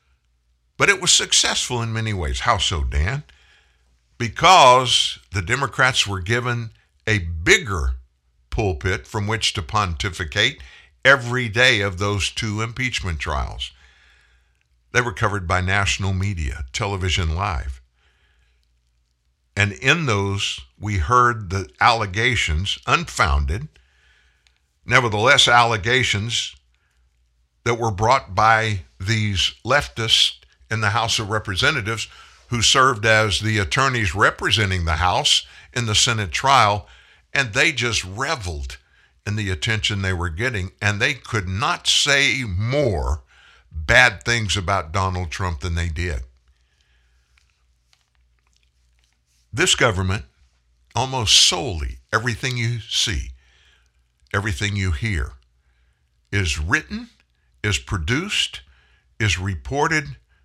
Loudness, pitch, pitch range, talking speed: -19 LUFS, 95 Hz, 65-110 Hz, 110 wpm